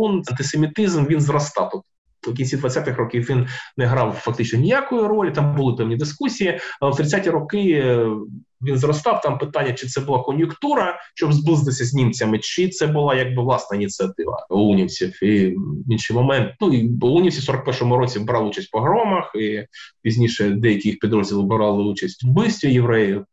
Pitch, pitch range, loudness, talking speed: 130 Hz, 115-150 Hz, -20 LUFS, 170 wpm